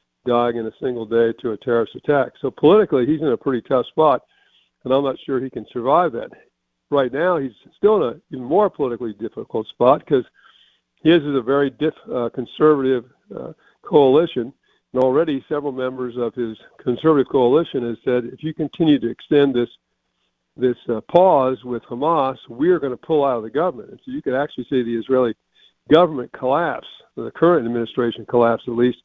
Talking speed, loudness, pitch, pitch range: 190 wpm, -19 LUFS, 125 Hz, 120-145 Hz